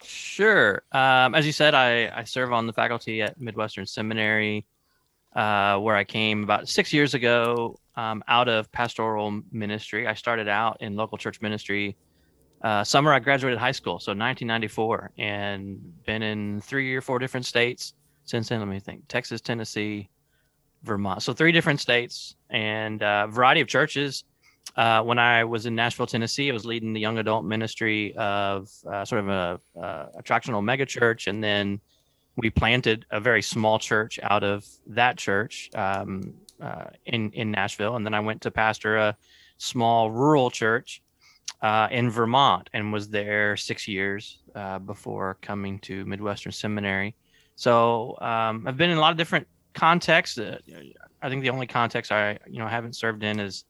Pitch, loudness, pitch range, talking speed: 110 Hz, -24 LUFS, 105-120 Hz, 170 wpm